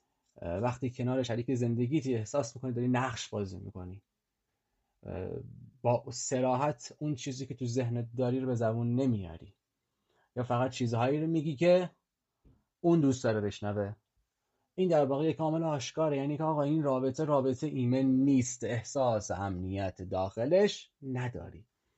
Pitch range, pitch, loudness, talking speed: 110-140 Hz, 125 Hz, -32 LUFS, 140 wpm